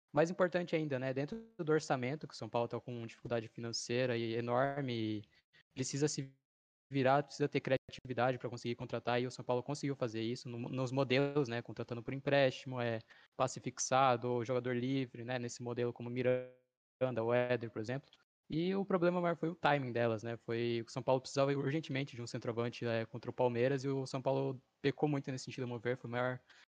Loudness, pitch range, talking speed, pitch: -37 LUFS, 120-140 Hz, 205 wpm, 125 Hz